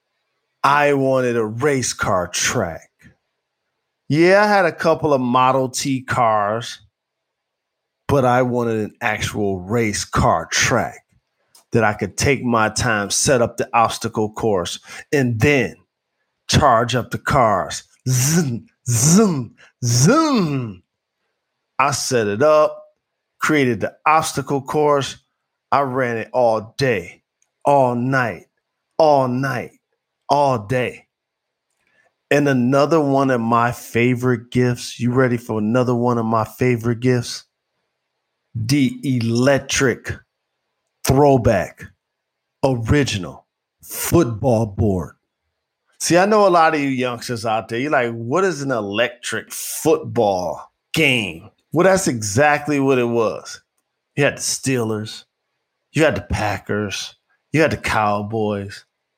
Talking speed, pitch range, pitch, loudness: 120 wpm, 115-145 Hz, 125 Hz, -18 LUFS